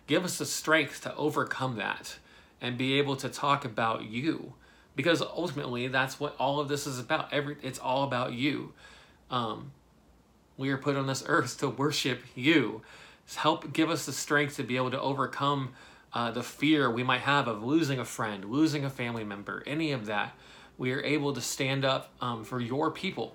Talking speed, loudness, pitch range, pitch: 195 wpm, -30 LUFS, 125-145 Hz, 135 Hz